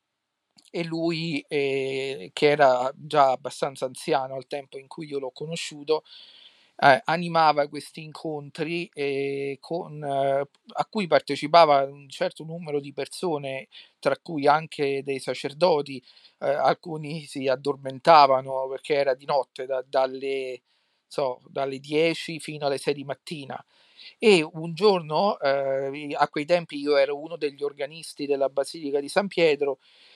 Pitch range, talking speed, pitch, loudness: 135-165 Hz, 140 wpm, 145 Hz, -25 LUFS